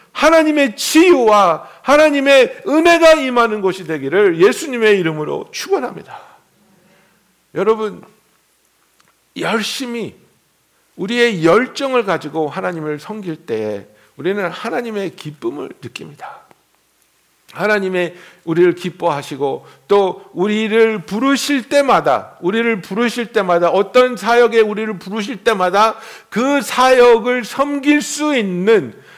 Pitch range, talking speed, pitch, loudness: 185-260 Hz, 255 characters per minute, 220 Hz, -15 LUFS